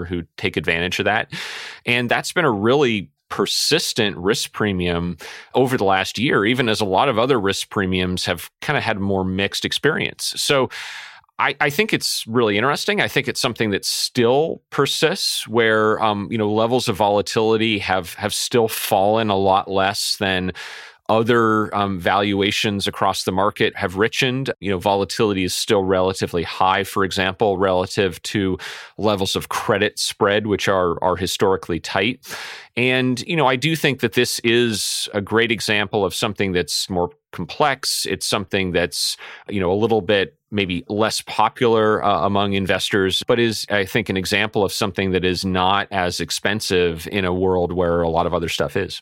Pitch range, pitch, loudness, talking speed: 95-115 Hz, 100 Hz, -19 LUFS, 175 wpm